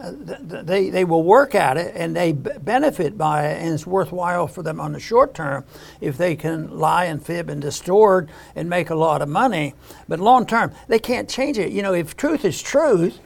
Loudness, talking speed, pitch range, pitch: -20 LUFS, 215 wpm, 155-195 Hz, 175 Hz